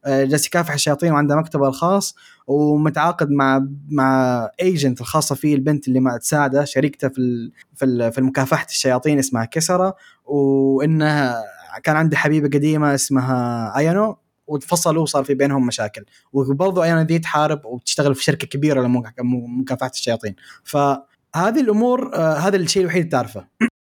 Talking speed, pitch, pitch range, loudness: 130 wpm, 140 Hz, 130-155 Hz, -19 LUFS